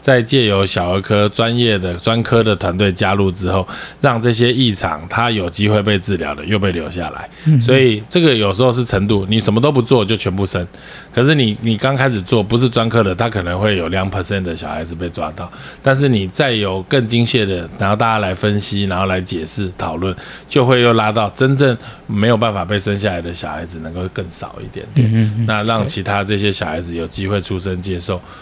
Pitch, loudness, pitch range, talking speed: 105 Hz, -16 LUFS, 95-115 Hz, 325 characters per minute